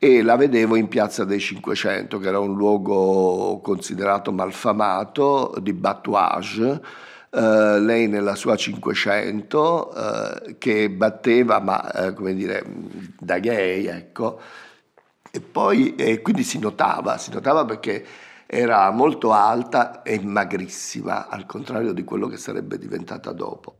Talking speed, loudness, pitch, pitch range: 130 wpm, -21 LUFS, 100 Hz, 95-110 Hz